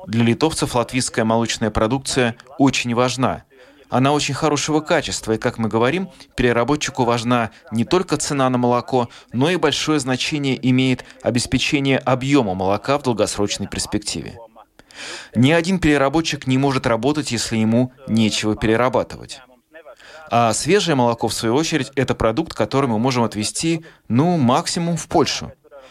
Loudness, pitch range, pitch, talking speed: -19 LUFS, 115-145 Hz, 130 Hz, 135 wpm